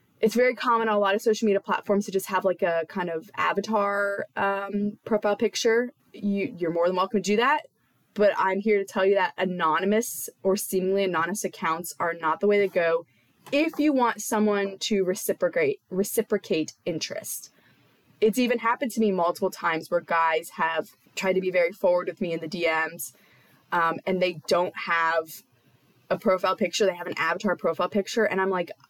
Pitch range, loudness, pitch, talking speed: 175-215 Hz, -25 LUFS, 195 Hz, 190 wpm